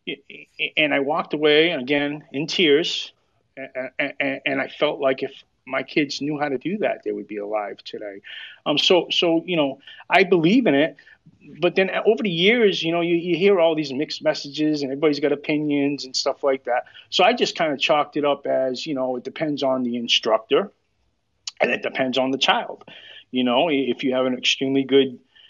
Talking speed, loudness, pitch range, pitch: 200 wpm, -21 LUFS, 130-160 Hz, 145 Hz